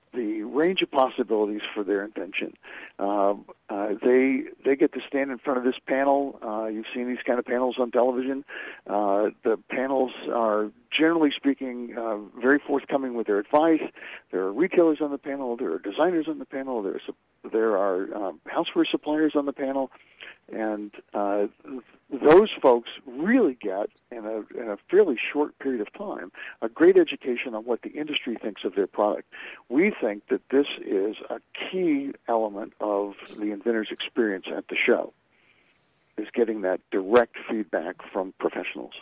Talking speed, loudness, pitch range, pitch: 170 wpm, -25 LUFS, 110-145 Hz, 125 Hz